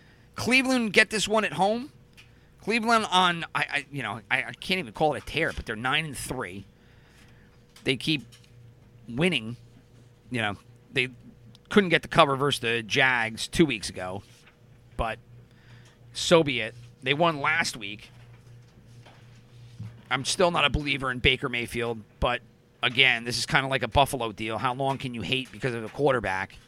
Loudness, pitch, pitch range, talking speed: -25 LUFS, 120 Hz, 120-145 Hz, 170 wpm